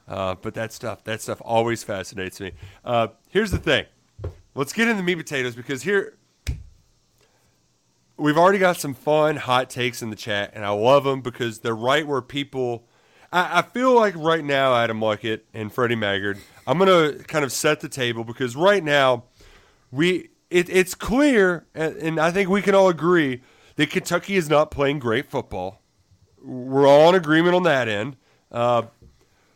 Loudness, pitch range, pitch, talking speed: -21 LUFS, 115-165 Hz, 135 Hz, 175 wpm